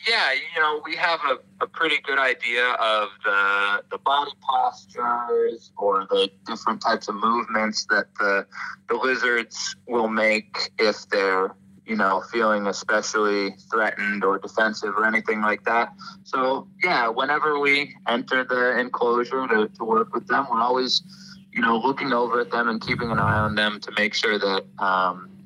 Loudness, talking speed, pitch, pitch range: -23 LUFS, 165 wpm, 120 Hz, 105-150 Hz